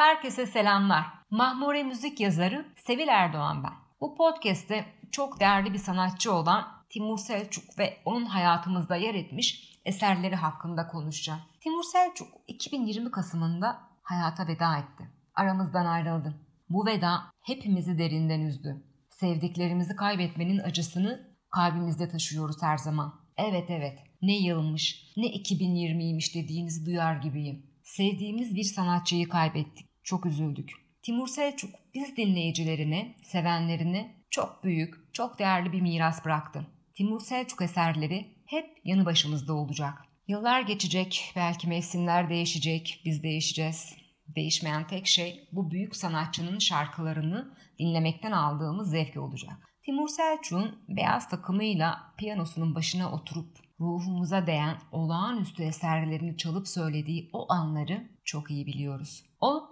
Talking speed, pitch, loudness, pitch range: 120 wpm, 175 Hz, -30 LUFS, 160-200 Hz